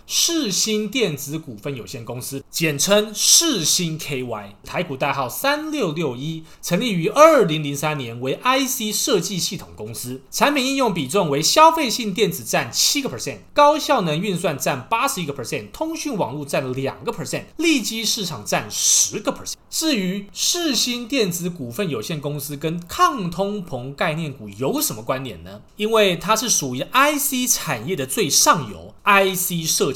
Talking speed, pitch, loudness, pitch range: 300 characters per minute, 180 Hz, -19 LUFS, 145-235 Hz